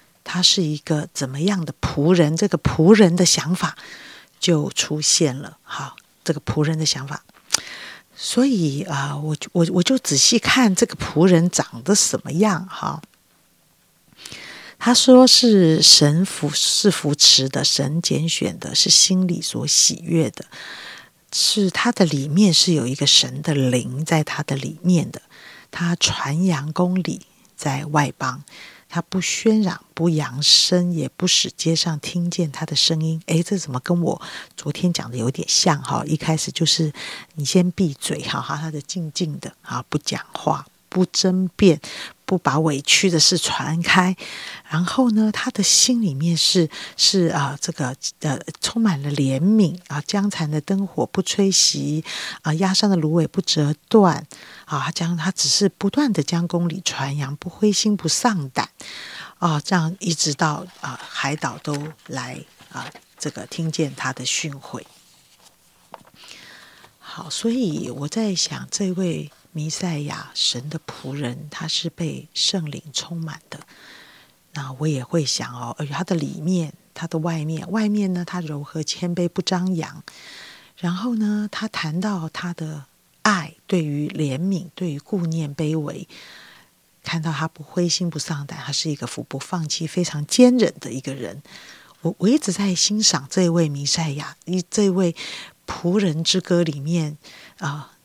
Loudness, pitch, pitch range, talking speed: -19 LUFS, 165 Hz, 150-185 Hz, 220 characters per minute